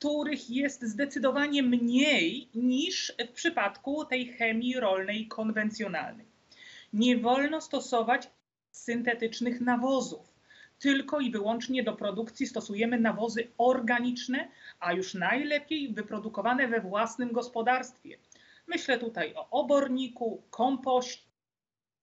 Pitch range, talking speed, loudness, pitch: 230-275 Hz, 100 wpm, -30 LUFS, 245 Hz